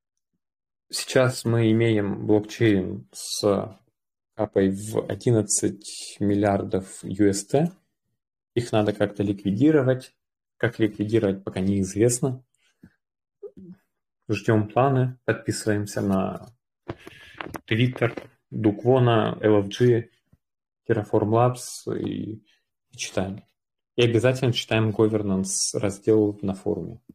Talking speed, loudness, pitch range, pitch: 80 wpm, -24 LUFS, 105-120 Hz, 110 Hz